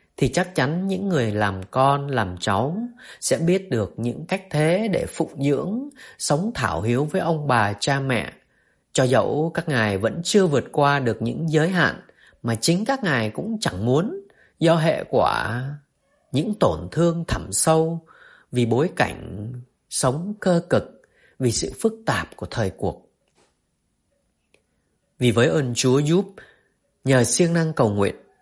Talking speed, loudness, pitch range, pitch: 160 wpm, -22 LUFS, 115-175 Hz, 145 Hz